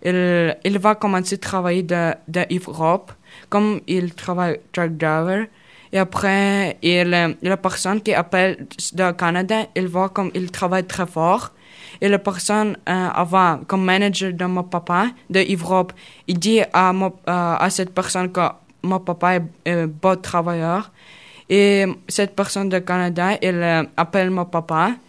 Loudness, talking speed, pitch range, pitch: -19 LUFS, 150 wpm, 175-195 Hz, 185 Hz